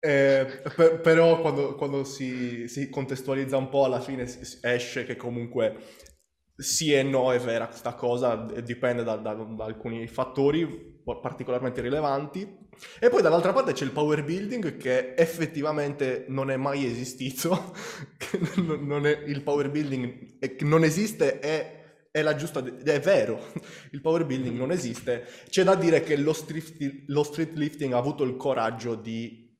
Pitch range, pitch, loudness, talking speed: 125-155 Hz, 140 Hz, -27 LUFS, 155 wpm